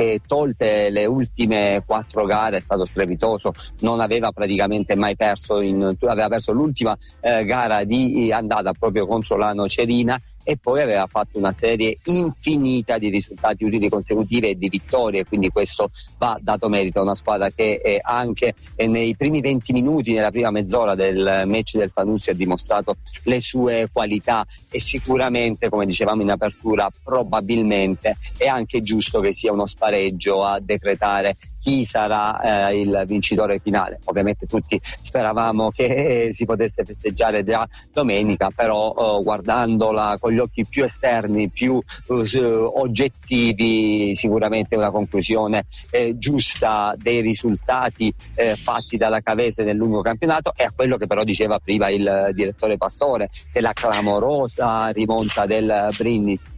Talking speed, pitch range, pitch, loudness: 145 wpm, 100-115 Hz, 110 Hz, -20 LUFS